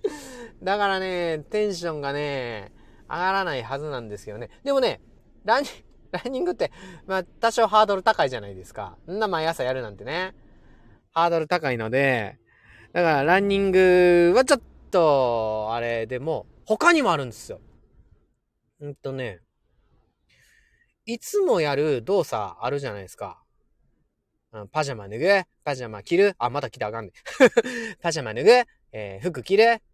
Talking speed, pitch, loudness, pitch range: 305 characters per minute, 175 Hz, -23 LUFS, 130-215 Hz